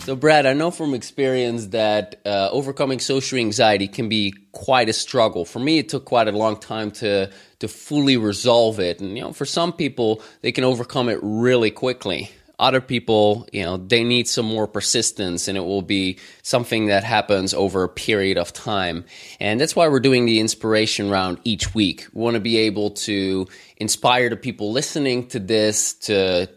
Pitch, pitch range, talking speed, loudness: 110 Hz, 100-125 Hz, 190 wpm, -20 LUFS